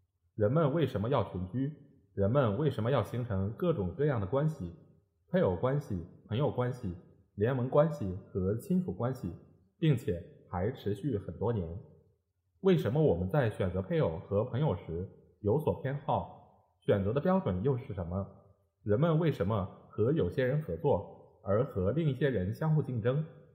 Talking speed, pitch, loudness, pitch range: 245 characters per minute, 115 Hz, -32 LUFS, 95-145 Hz